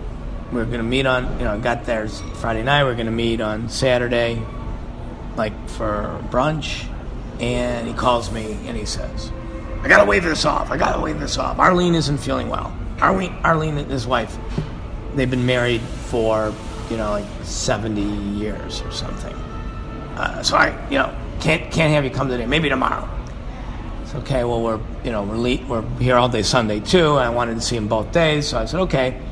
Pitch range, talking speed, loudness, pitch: 110-130 Hz, 205 wpm, -20 LUFS, 120 Hz